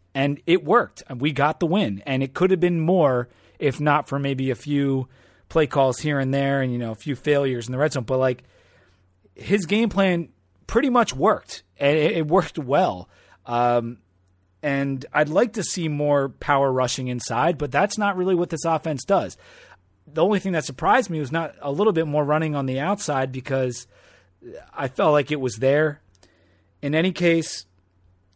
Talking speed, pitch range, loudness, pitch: 190 wpm, 125-165 Hz, -22 LUFS, 140 Hz